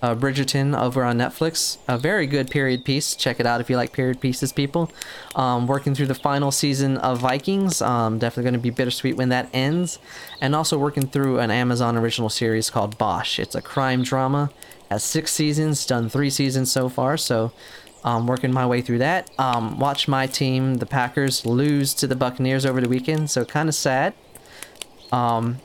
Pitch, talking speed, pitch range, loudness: 130 Hz, 195 wpm, 125-140 Hz, -22 LUFS